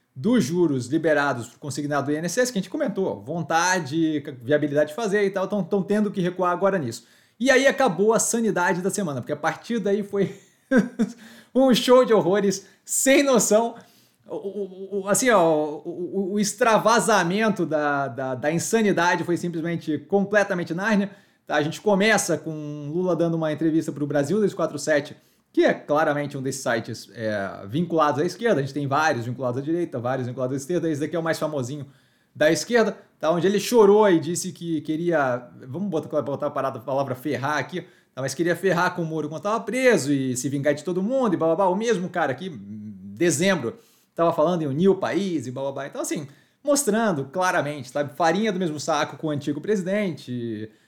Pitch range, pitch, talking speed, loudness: 145-200 Hz, 170 Hz, 195 wpm, -23 LUFS